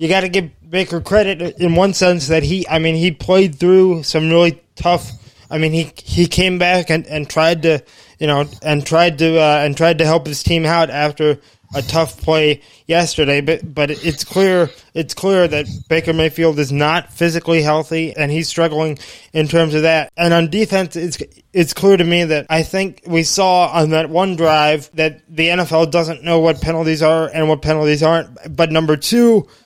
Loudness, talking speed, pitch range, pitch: -15 LUFS, 200 wpm, 155-175 Hz, 160 Hz